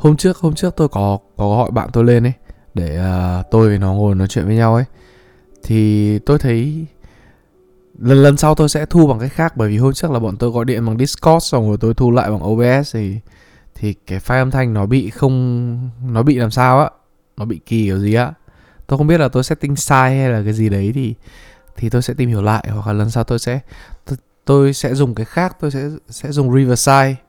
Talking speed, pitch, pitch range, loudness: 235 wpm, 125 Hz, 110-140 Hz, -15 LUFS